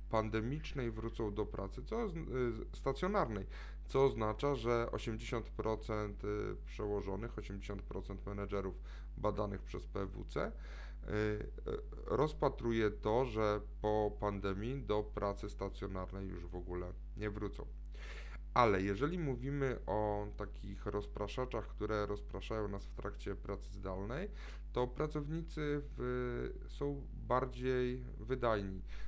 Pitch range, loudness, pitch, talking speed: 100-125 Hz, -40 LUFS, 105 Hz, 100 wpm